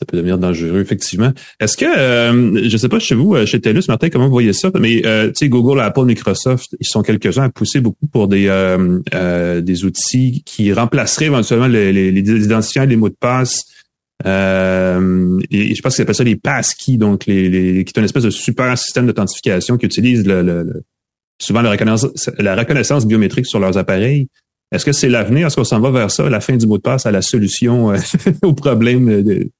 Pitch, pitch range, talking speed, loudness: 110 Hz, 100-125 Hz, 215 wpm, -14 LUFS